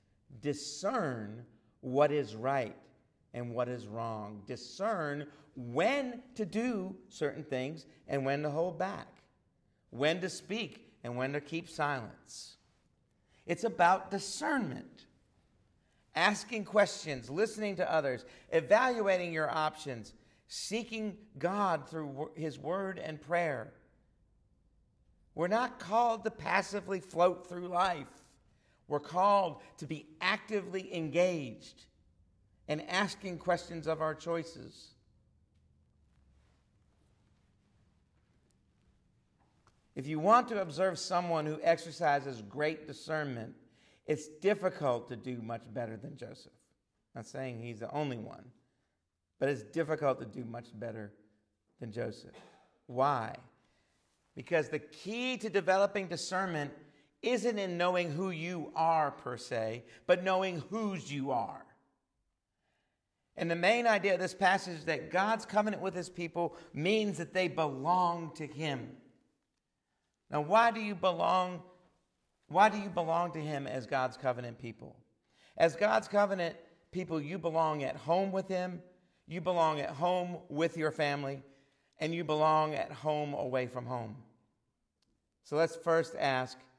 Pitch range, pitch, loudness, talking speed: 130-185 Hz, 155 Hz, -34 LUFS, 125 wpm